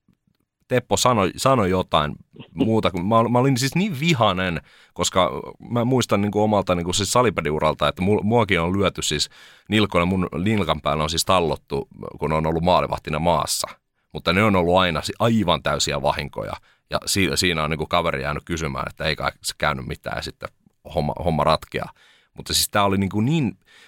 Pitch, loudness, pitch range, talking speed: 95 Hz, -21 LUFS, 80-110 Hz, 175 wpm